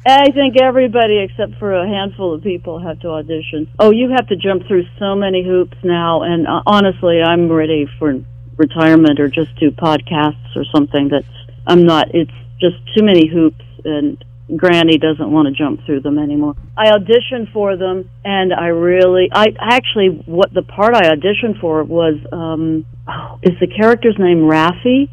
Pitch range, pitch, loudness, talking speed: 155-195 Hz, 170 Hz, -13 LUFS, 175 wpm